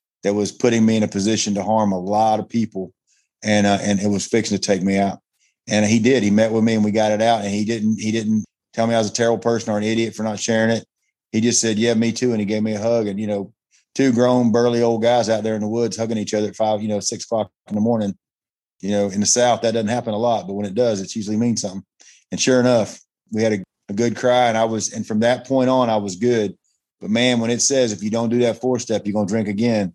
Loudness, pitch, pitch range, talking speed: -19 LUFS, 110 Hz, 105-115 Hz, 290 wpm